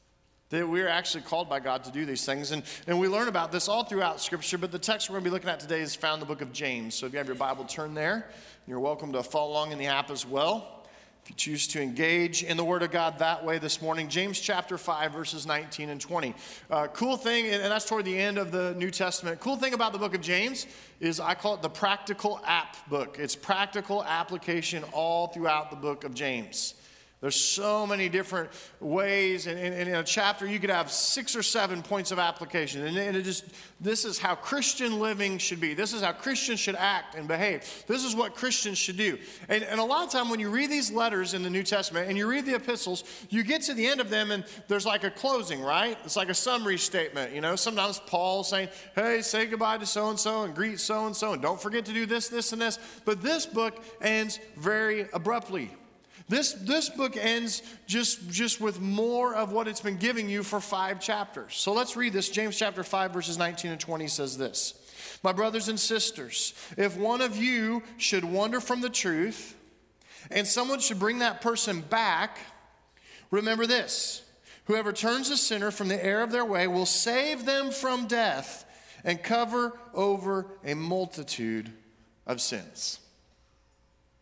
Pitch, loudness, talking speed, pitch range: 195 Hz, -28 LUFS, 210 wpm, 170-225 Hz